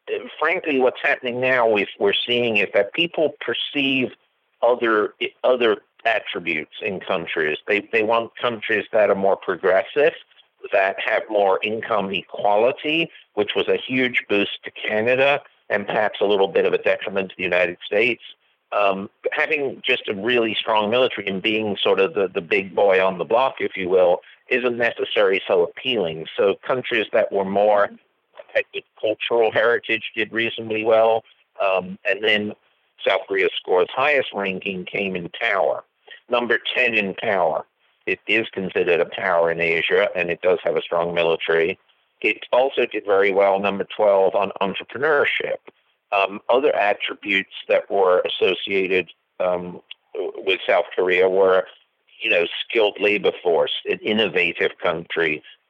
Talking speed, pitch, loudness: 150 wpm, 145 Hz, -20 LUFS